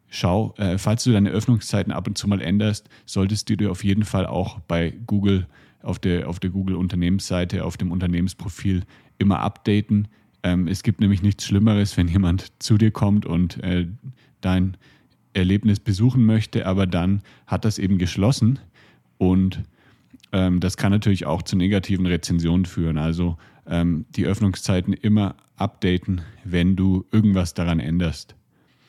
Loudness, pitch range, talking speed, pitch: -22 LUFS, 90-105 Hz, 155 wpm, 95 Hz